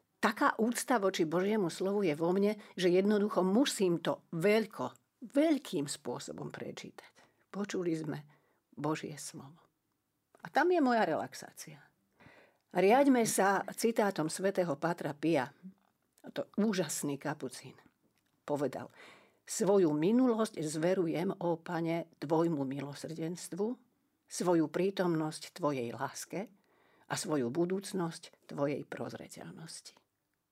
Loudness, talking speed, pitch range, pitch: -33 LUFS, 100 wpm, 155-210 Hz, 180 Hz